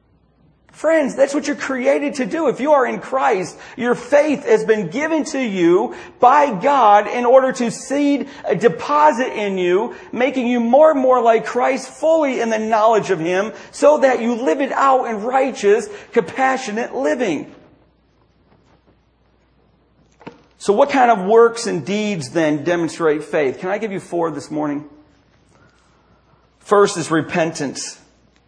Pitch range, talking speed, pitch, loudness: 195-275 Hz, 150 wpm, 235 Hz, -17 LUFS